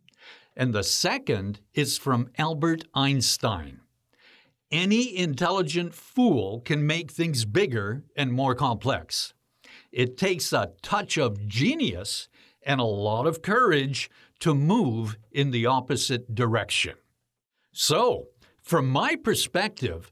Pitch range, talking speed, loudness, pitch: 120-165 Hz, 115 wpm, -25 LUFS, 135 Hz